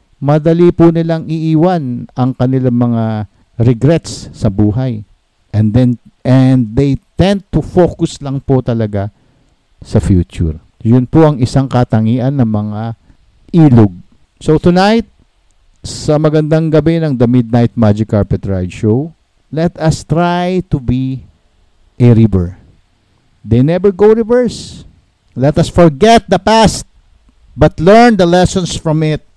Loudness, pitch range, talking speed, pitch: -11 LUFS, 110-160 Hz, 130 wpm, 130 Hz